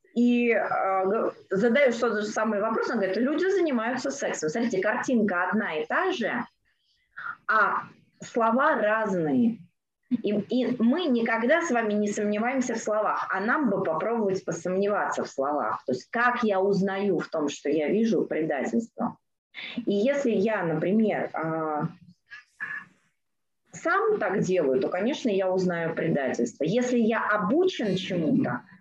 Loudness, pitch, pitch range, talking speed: -26 LUFS, 215 Hz, 190-245 Hz, 135 wpm